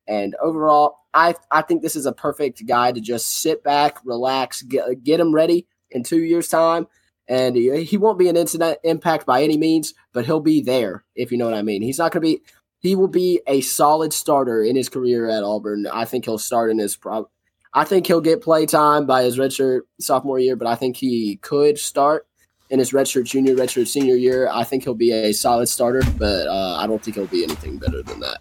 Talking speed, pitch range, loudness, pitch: 225 wpm, 120-160 Hz, -19 LUFS, 135 Hz